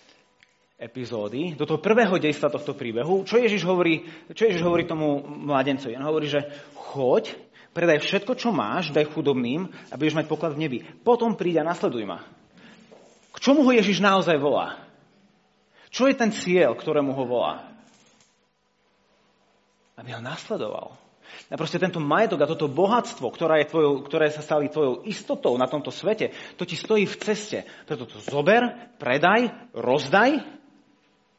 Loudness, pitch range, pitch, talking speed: -24 LUFS, 150-220 Hz, 170 Hz, 145 wpm